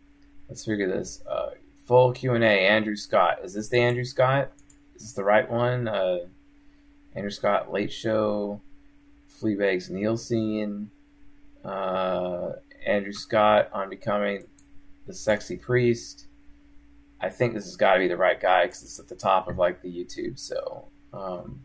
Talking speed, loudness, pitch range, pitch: 150 wpm, -25 LUFS, 95-125 Hz, 105 Hz